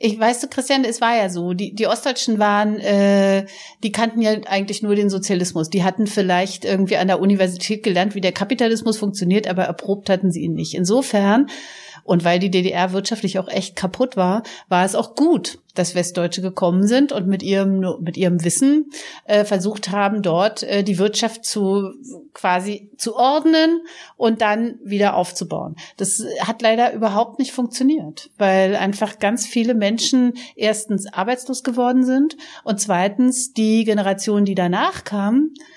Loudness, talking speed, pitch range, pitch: -19 LUFS, 165 wpm, 190-235 Hz, 205 Hz